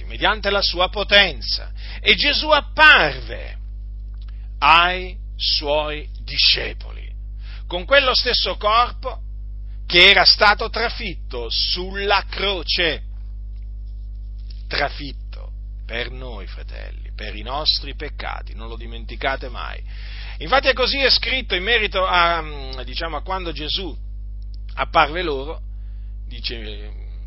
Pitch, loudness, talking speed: 115 Hz, -17 LUFS, 105 wpm